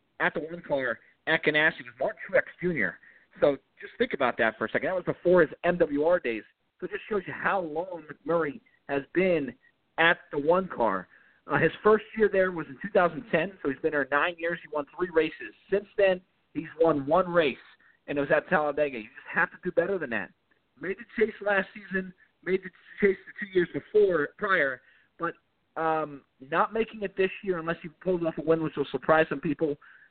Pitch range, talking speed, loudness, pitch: 150-185 Hz, 210 wpm, -28 LUFS, 170 Hz